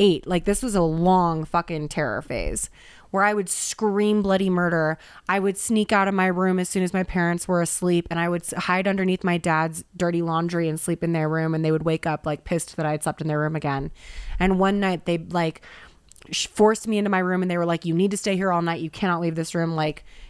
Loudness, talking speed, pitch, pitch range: -23 LUFS, 250 wpm, 175 Hz, 160-190 Hz